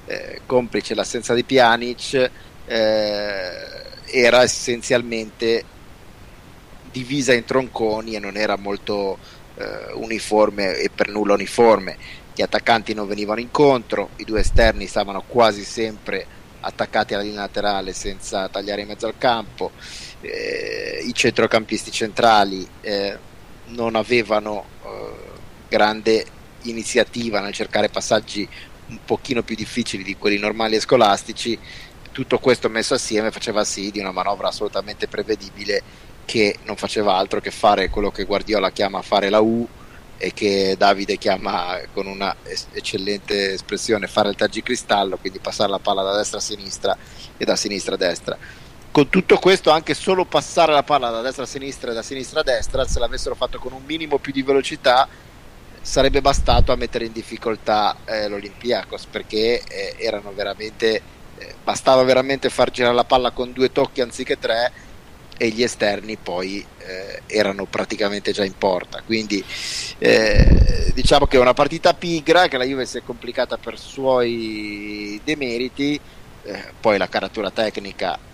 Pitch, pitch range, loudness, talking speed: 115 Hz, 105-130 Hz, -20 LUFS, 150 wpm